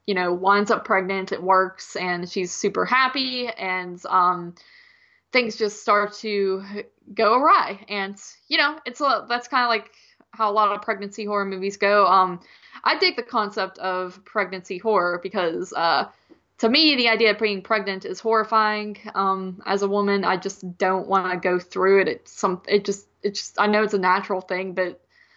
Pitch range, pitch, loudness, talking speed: 190-225 Hz, 200 Hz, -22 LUFS, 185 wpm